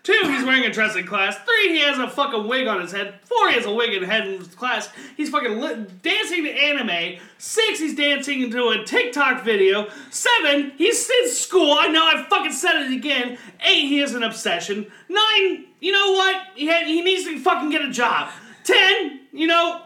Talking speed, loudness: 215 wpm, -19 LUFS